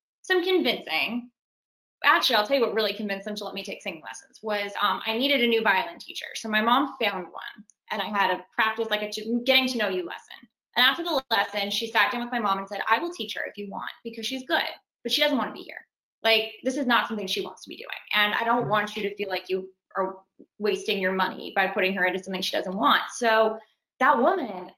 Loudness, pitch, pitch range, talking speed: -25 LUFS, 220 Hz, 200-245 Hz, 250 wpm